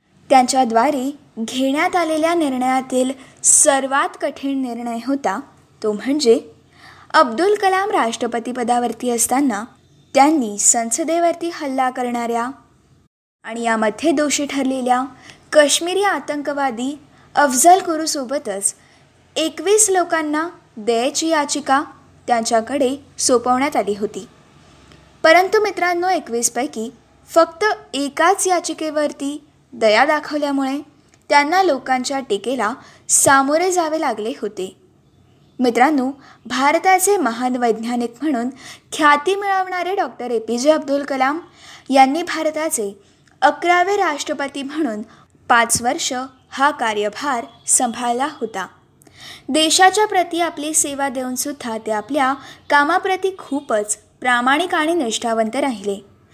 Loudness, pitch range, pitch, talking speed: -18 LUFS, 245-320 Hz, 280 Hz, 90 wpm